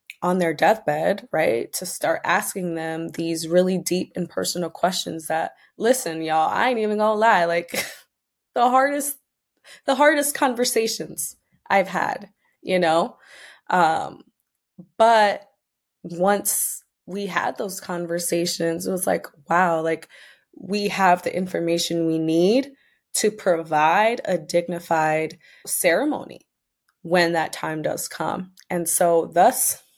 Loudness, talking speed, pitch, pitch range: -22 LUFS, 125 wpm, 180 Hz, 165-210 Hz